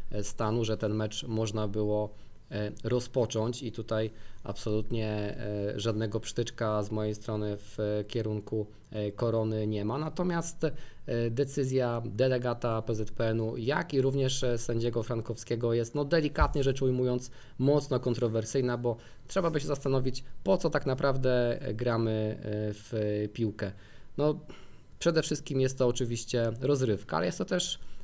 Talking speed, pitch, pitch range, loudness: 125 wpm, 115 Hz, 110-130 Hz, -31 LUFS